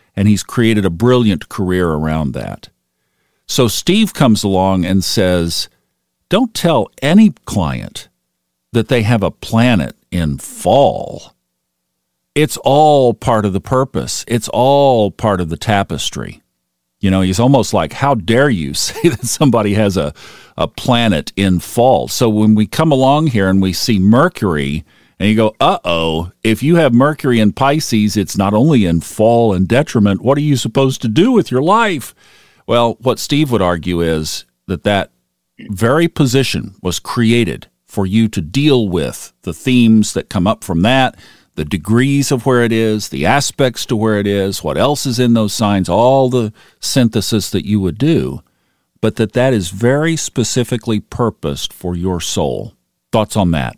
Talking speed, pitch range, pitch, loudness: 170 wpm, 90-125 Hz, 110 Hz, -14 LUFS